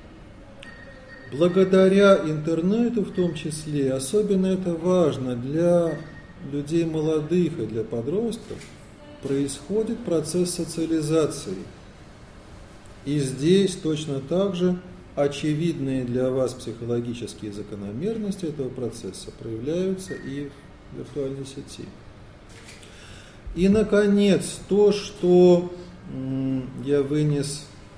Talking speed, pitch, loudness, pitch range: 85 wpm, 150 Hz, -23 LUFS, 130-180 Hz